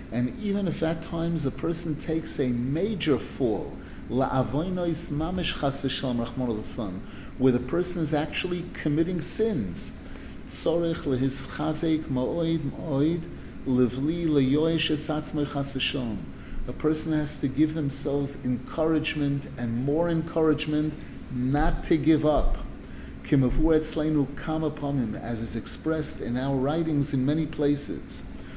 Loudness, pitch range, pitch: -27 LUFS, 130-160 Hz, 150 Hz